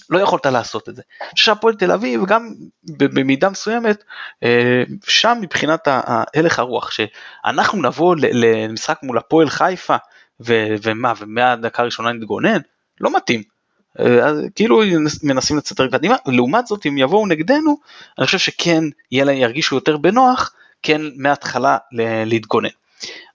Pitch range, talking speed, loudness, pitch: 120-190 Hz, 140 wpm, -16 LUFS, 145 Hz